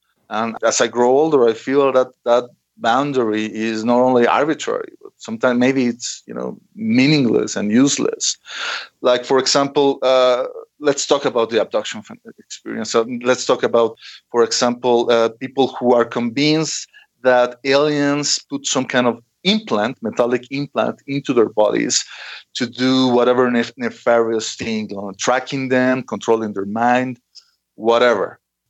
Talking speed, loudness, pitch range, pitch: 150 wpm, -17 LUFS, 120-140 Hz, 125 Hz